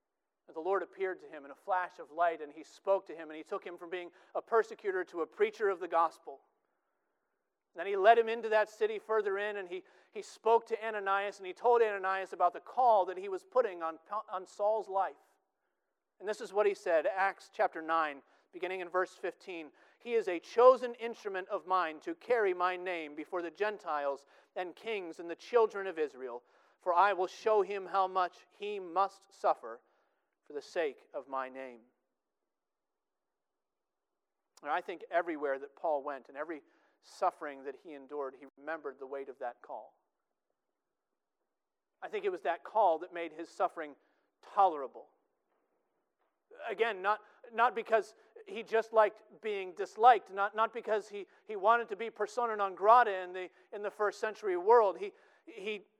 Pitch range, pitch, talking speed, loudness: 180-250 Hz, 205 Hz, 180 wpm, -33 LUFS